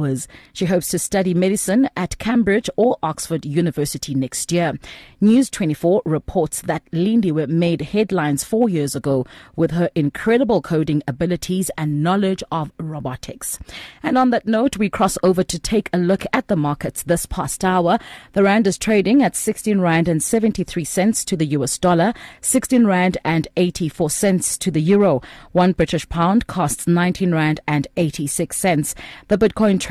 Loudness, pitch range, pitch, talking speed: -19 LUFS, 160-205 Hz, 180 Hz, 165 wpm